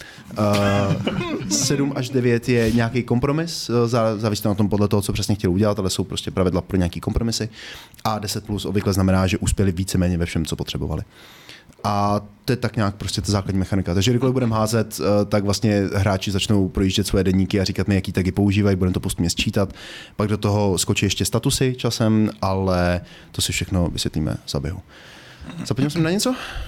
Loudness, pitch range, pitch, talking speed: -21 LUFS, 95-110 Hz, 105 Hz, 190 wpm